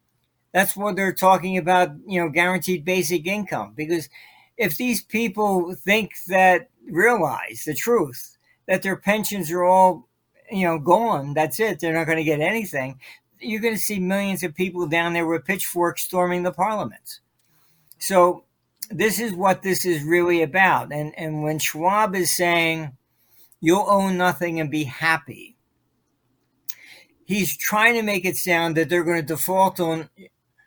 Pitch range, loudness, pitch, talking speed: 165-190 Hz, -21 LUFS, 180 Hz, 155 wpm